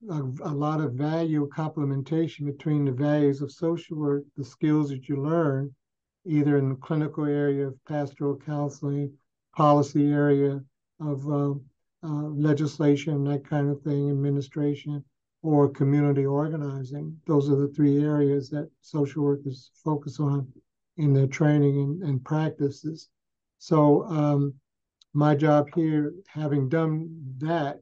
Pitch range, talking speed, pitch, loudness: 140-150 Hz, 135 wpm, 145 Hz, -26 LUFS